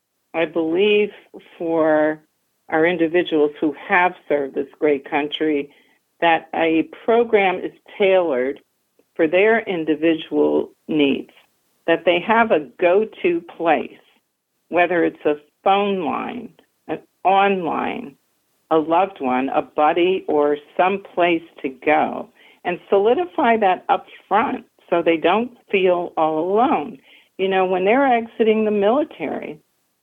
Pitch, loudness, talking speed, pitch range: 175 Hz, -19 LUFS, 120 wpm, 155-195 Hz